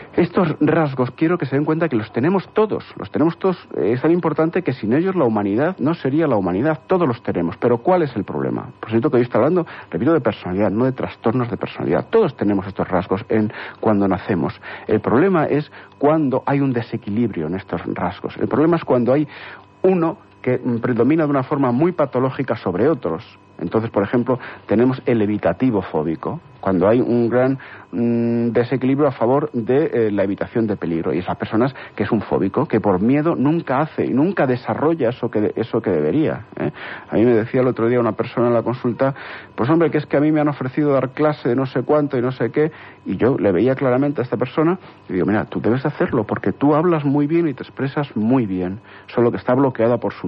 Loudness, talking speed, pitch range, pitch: -19 LUFS, 220 wpm, 110-150 Hz, 125 Hz